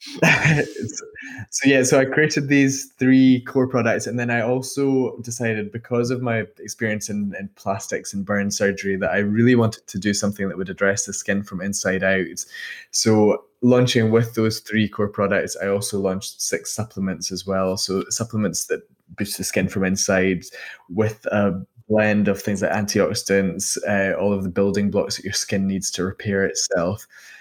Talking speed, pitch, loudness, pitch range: 180 wpm, 105 Hz, -21 LUFS, 100-120 Hz